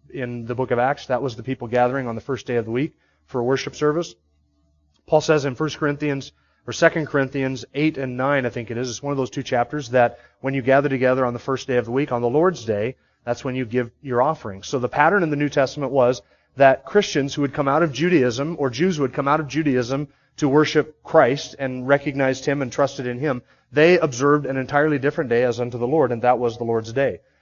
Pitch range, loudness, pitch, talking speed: 125-145 Hz, -21 LUFS, 135 Hz, 250 wpm